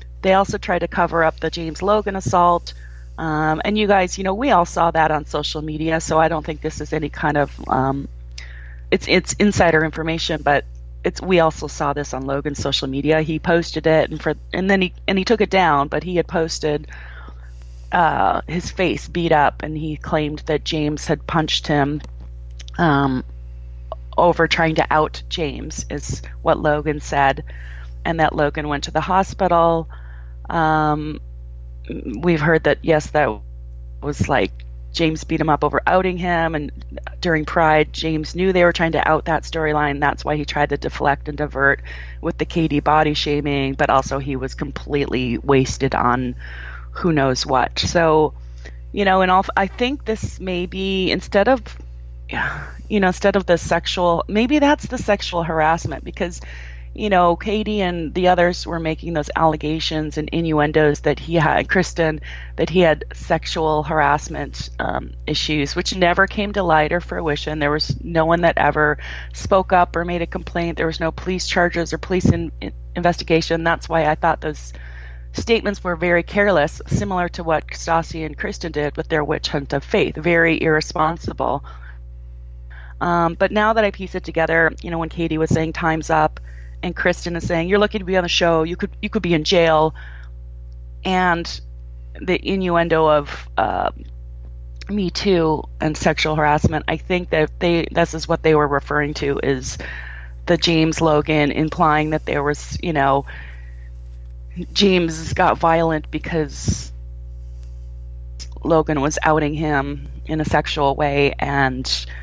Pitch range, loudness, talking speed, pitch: 135-170 Hz, -19 LUFS, 170 wpm, 155 Hz